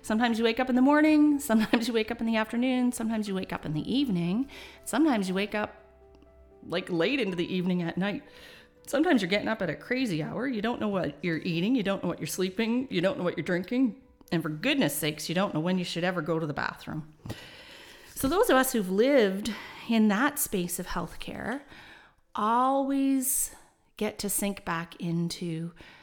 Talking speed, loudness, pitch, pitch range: 210 wpm, -28 LUFS, 205 Hz, 170-245 Hz